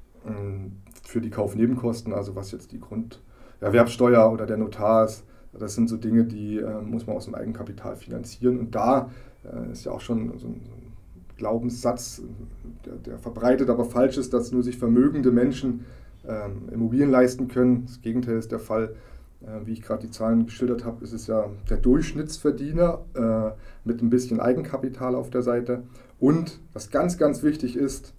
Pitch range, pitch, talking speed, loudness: 110-125 Hz, 120 Hz, 170 wpm, -24 LUFS